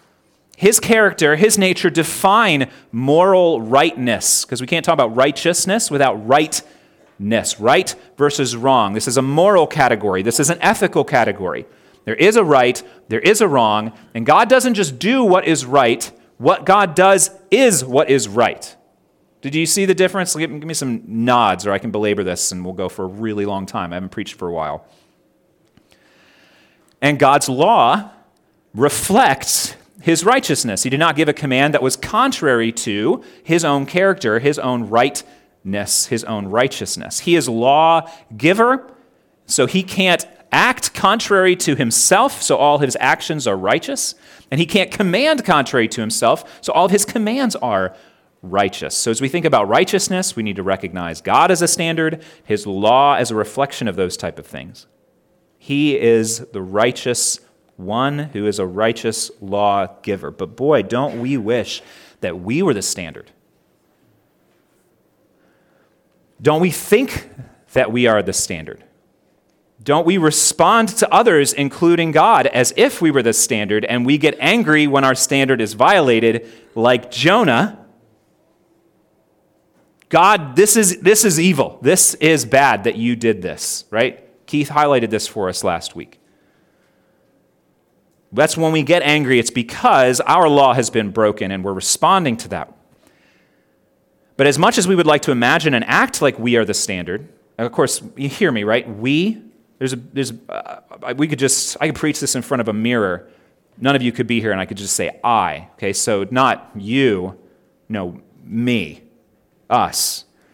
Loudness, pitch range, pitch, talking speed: -16 LUFS, 115-170 Hz, 140 Hz, 170 wpm